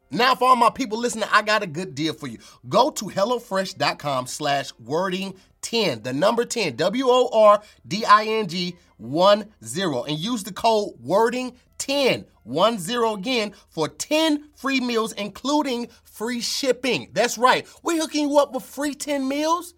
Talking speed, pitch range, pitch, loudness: 165 wpm, 195-260 Hz, 225 Hz, -22 LUFS